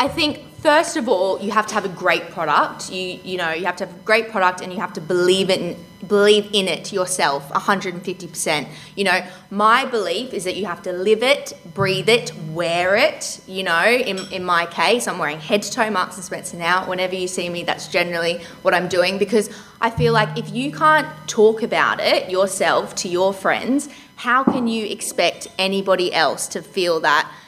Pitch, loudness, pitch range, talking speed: 190 Hz, -19 LUFS, 180-215 Hz, 205 wpm